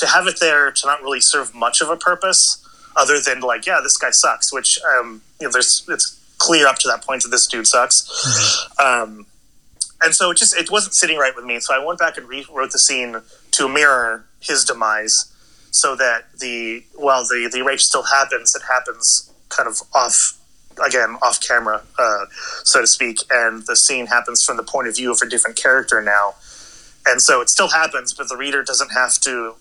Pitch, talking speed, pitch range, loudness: 130 Hz, 210 wpm, 115-165 Hz, -15 LUFS